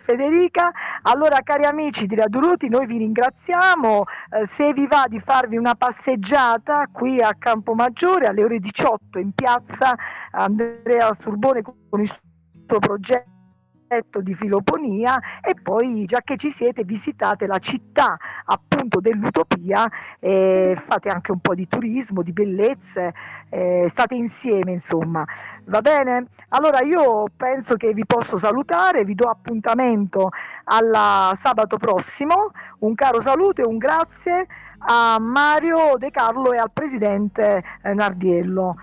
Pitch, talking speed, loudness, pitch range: 230 Hz, 135 wpm, -19 LUFS, 205-265 Hz